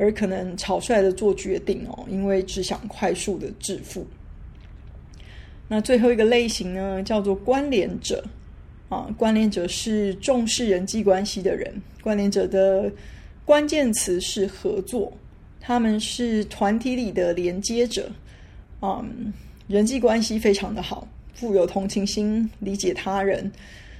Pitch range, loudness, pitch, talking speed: 195-225 Hz, -23 LUFS, 205 Hz, 210 characters per minute